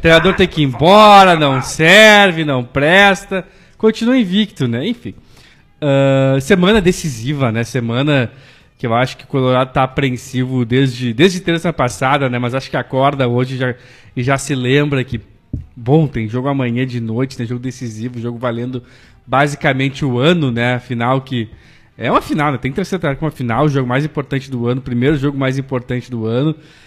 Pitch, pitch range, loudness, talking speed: 135 Hz, 125-150 Hz, -14 LUFS, 185 wpm